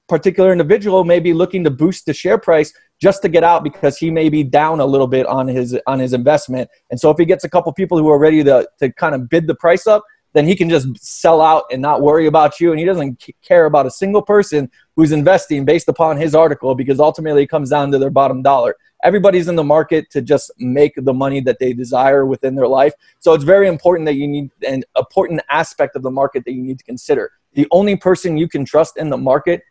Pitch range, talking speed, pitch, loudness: 140-175 Hz, 250 wpm, 155 Hz, -14 LUFS